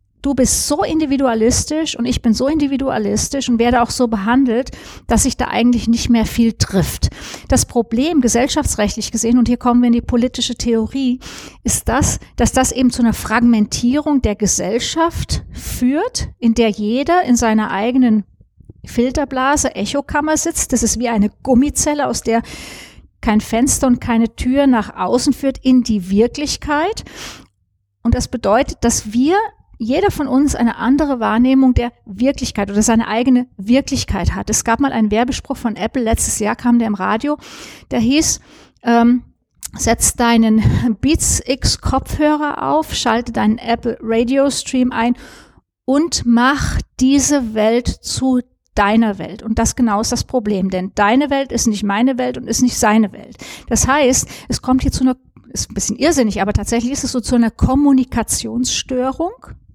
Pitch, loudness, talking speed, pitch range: 245 Hz, -16 LUFS, 165 wpm, 230-270 Hz